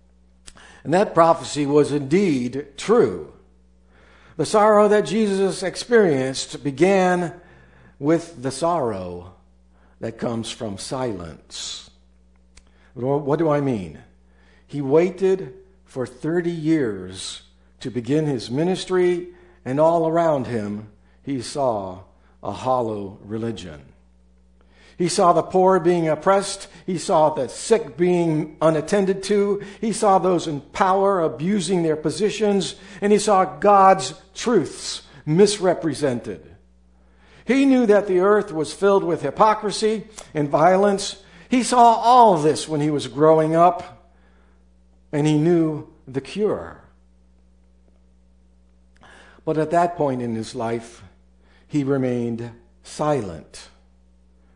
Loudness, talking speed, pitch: -20 LUFS, 115 wpm, 145 Hz